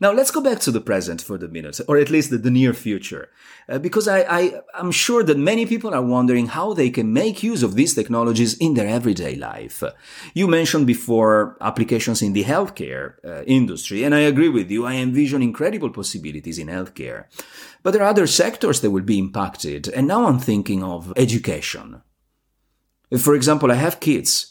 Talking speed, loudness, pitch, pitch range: 195 wpm, -19 LUFS, 125 Hz, 110-165 Hz